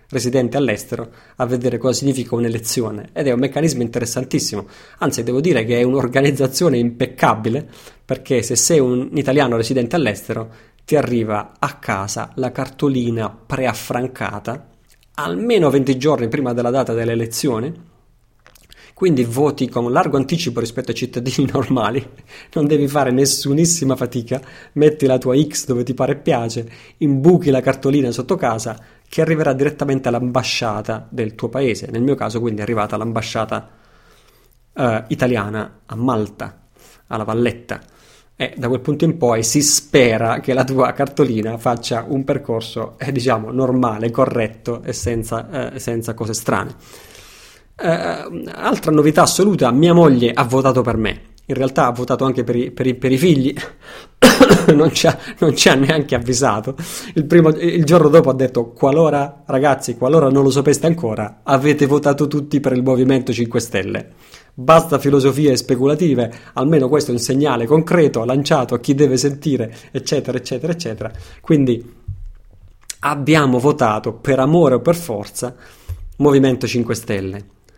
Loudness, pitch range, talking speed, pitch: -17 LUFS, 115-140 Hz, 145 wpm, 130 Hz